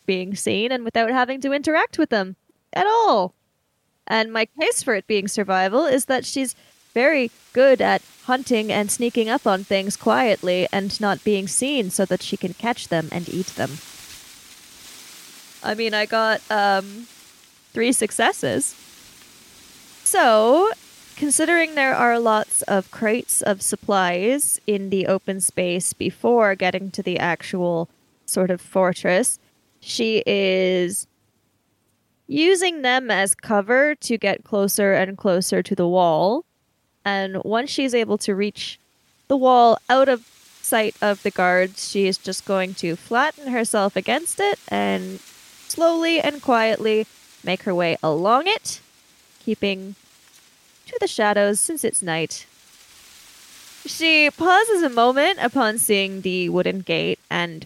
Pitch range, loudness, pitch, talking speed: 190-255 Hz, -20 LUFS, 210 Hz, 140 wpm